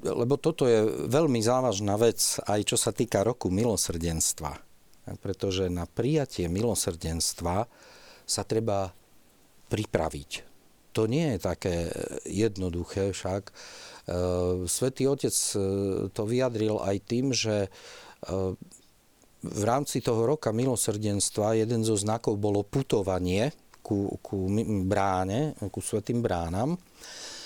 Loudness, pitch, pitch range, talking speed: -28 LUFS, 105 Hz, 95-120 Hz, 105 wpm